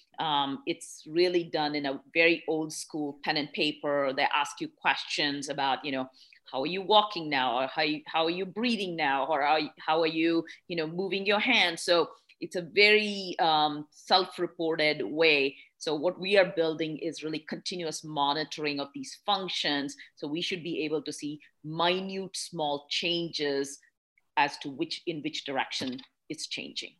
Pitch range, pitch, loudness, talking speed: 150-185 Hz, 160 Hz, -29 LUFS, 180 wpm